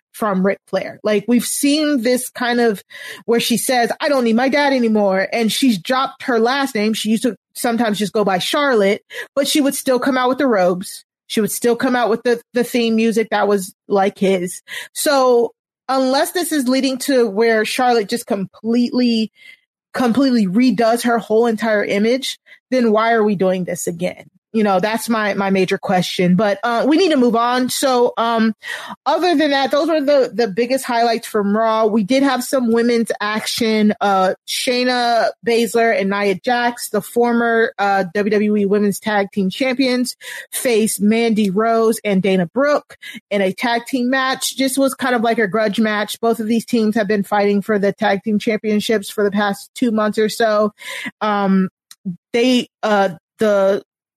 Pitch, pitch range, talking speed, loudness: 230 Hz, 210-250 Hz, 185 wpm, -17 LUFS